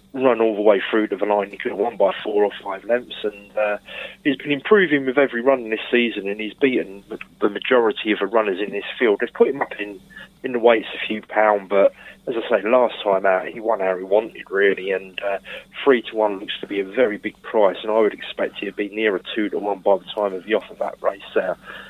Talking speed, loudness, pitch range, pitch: 265 wpm, -21 LUFS, 100-120 Hz, 110 Hz